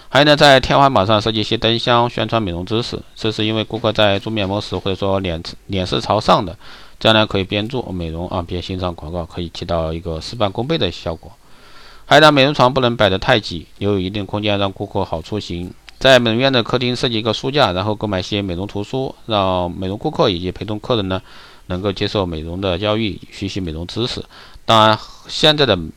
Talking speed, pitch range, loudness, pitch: 340 characters per minute, 90-110 Hz, -17 LUFS, 105 Hz